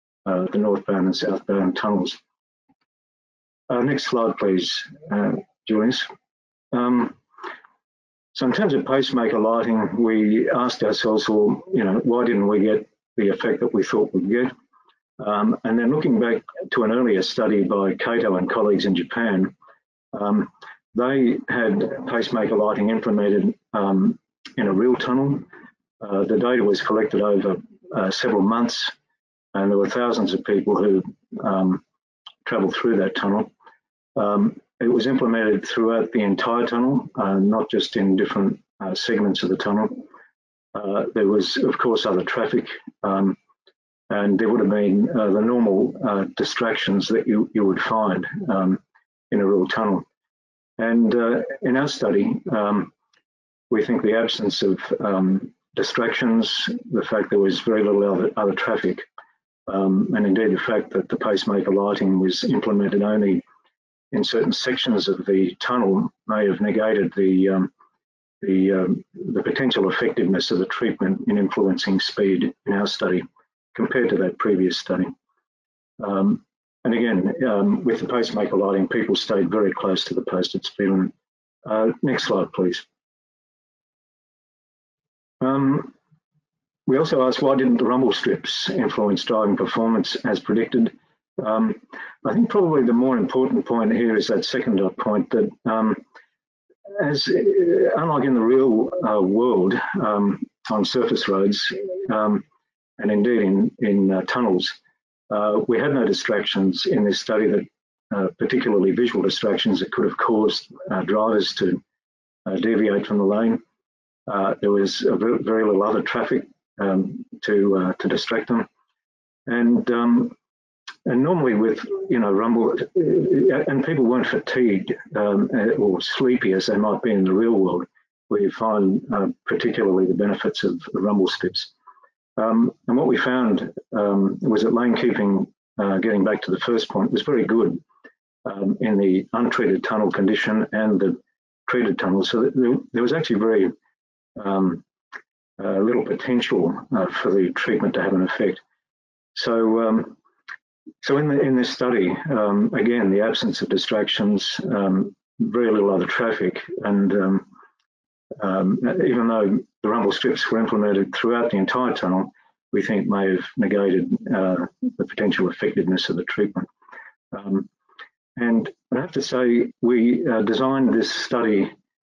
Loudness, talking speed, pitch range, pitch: -21 LUFS, 155 wpm, 95-120 Hz, 105 Hz